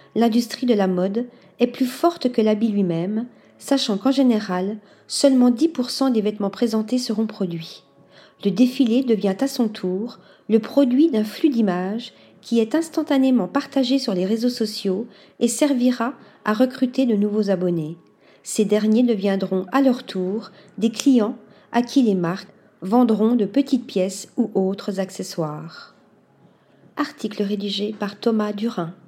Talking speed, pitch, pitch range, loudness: 145 wpm, 220 Hz, 200-250 Hz, -21 LUFS